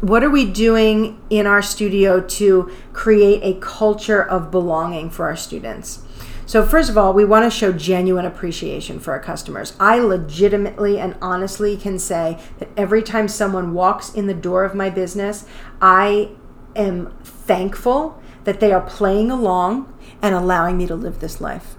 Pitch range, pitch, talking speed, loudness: 185-210 Hz, 200 Hz, 170 wpm, -17 LUFS